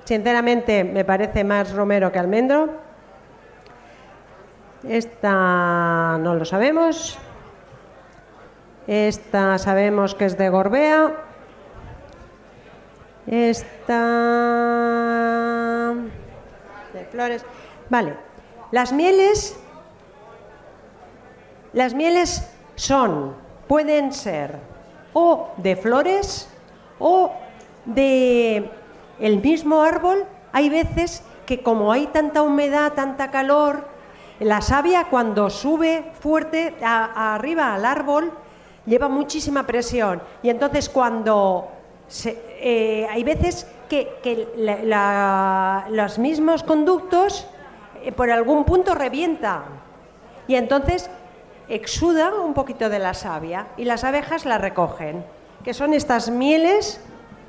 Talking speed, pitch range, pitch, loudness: 100 wpm, 210-300 Hz, 240 Hz, -20 LUFS